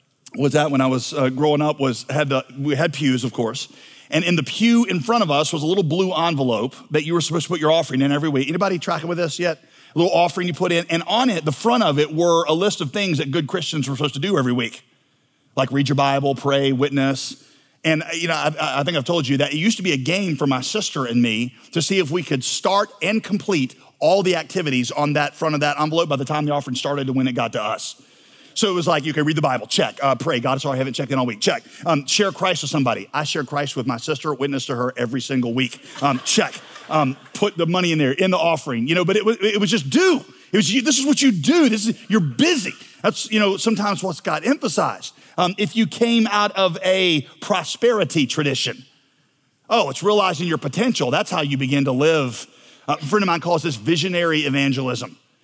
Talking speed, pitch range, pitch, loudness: 250 wpm, 140-185 Hz, 155 Hz, -20 LUFS